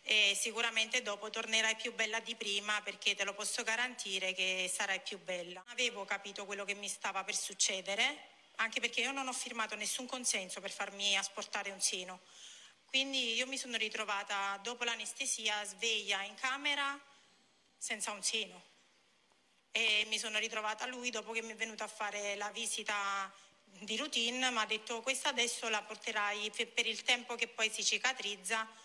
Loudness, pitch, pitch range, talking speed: -35 LUFS, 215 Hz, 200-235 Hz, 170 wpm